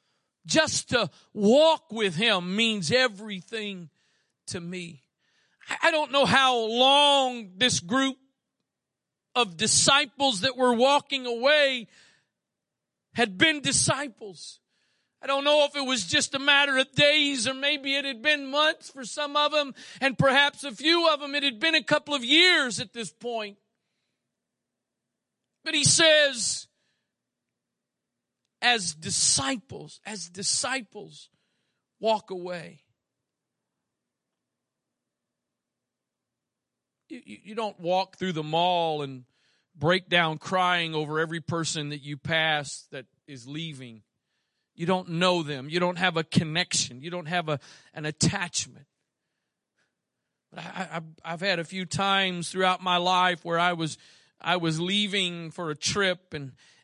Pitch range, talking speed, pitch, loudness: 170-270 Hz, 135 wpm, 200 Hz, -24 LUFS